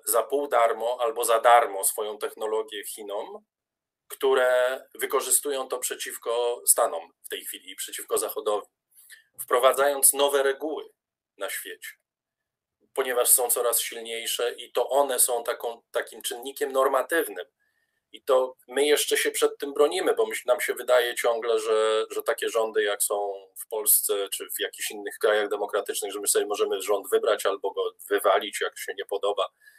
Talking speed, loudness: 155 wpm, -25 LUFS